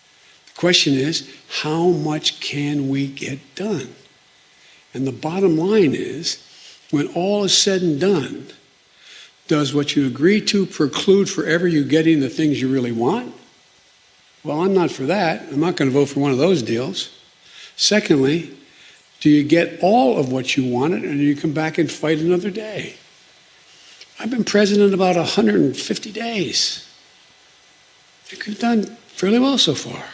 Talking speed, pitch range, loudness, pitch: 155 wpm, 145-195 Hz, -18 LUFS, 165 Hz